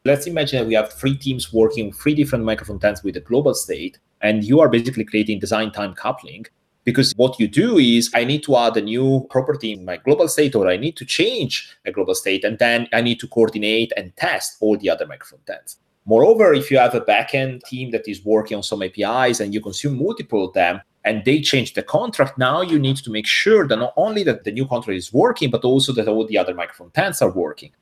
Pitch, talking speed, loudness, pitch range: 115 Hz, 235 wpm, -18 LUFS, 110-135 Hz